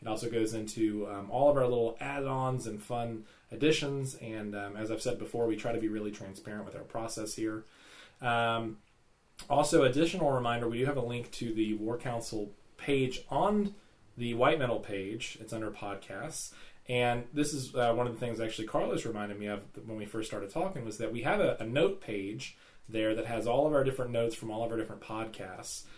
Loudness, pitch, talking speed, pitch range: -33 LUFS, 115 Hz, 210 wpm, 110-125 Hz